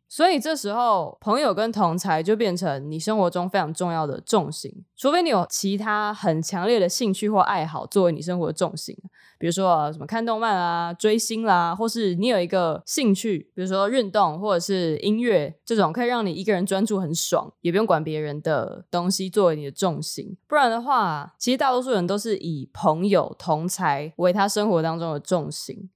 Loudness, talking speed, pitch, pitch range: -23 LUFS, 305 characters per minute, 190 Hz, 170-215 Hz